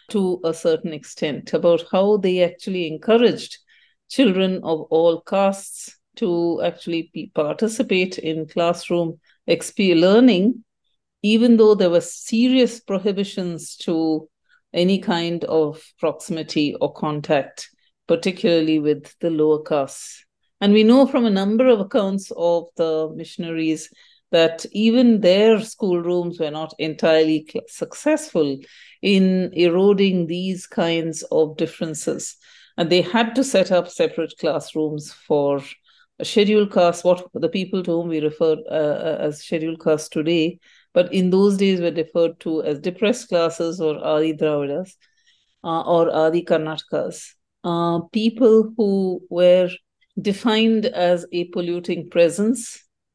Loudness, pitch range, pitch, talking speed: -20 LUFS, 165-205 Hz, 175 Hz, 130 wpm